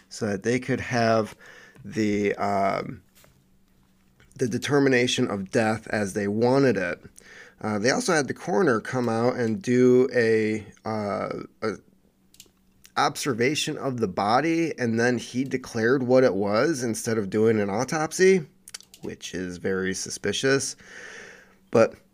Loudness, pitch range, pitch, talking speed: -24 LUFS, 100-125 Hz, 115 Hz, 135 wpm